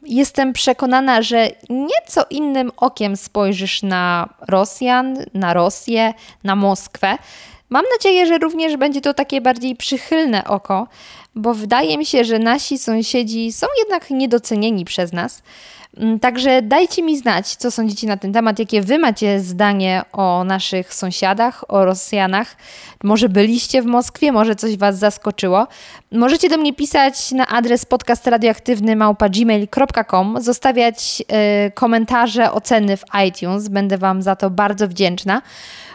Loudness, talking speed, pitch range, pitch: -16 LUFS, 135 wpm, 200-255 Hz, 225 Hz